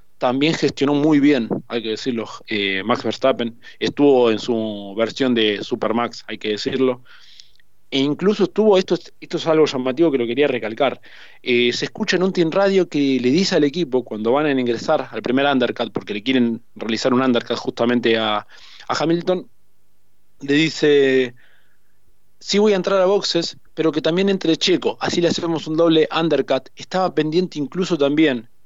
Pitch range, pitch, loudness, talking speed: 115-160 Hz, 135 Hz, -19 LUFS, 175 wpm